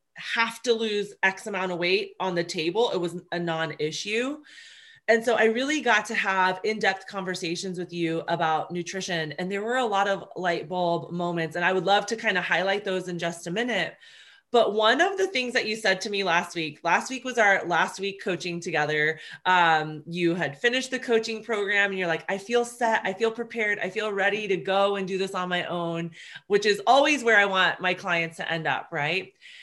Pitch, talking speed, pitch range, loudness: 195 Hz, 225 wpm, 175-225 Hz, -25 LUFS